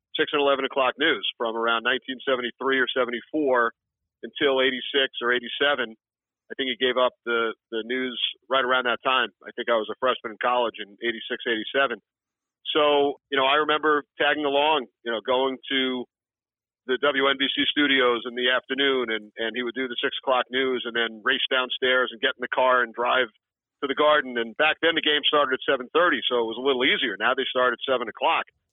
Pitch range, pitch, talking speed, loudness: 120-140 Hz, 130 Hz, 200 wpm, -24 LUFS